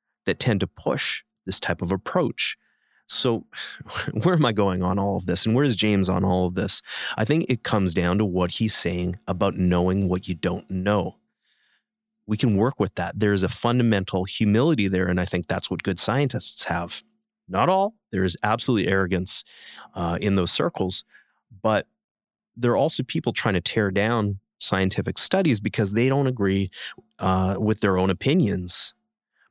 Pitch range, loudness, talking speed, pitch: 95-115 Hz, -23 LUFS, 180 wpm, 100 Hz